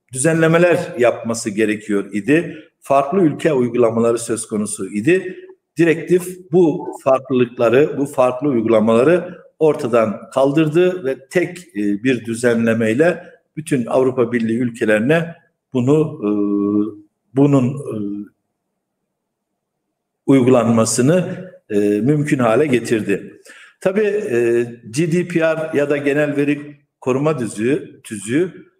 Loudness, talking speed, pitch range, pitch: -17 LUFS, 85 wpm, 115-165 Hz, 135 Hz